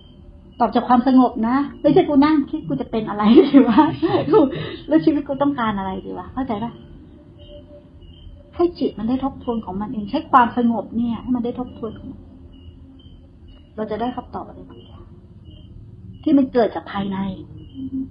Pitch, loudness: 230 Hz, -19 LUFS